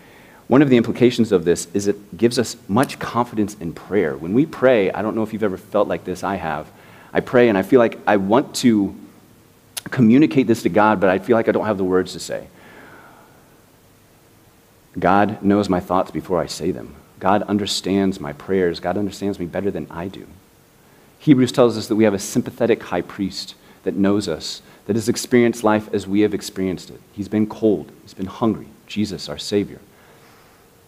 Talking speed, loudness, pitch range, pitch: 200 wpm, -19 LUFS, 95-110 Hz, 100 Hz